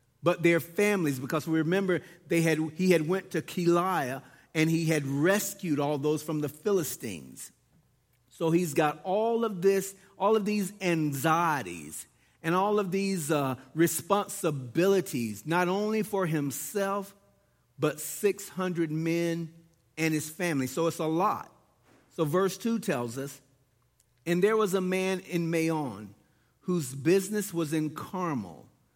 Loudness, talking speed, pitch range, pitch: -29 LUFS, 145 wpm, 150-190 Hz, 165 Hz